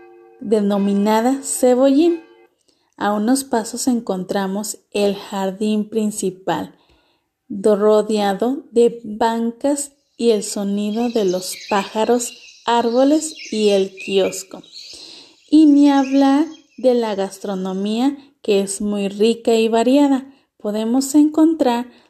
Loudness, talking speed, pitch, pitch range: -18 LUFS, 100 wpm, 230 Hz, 205-270 Hz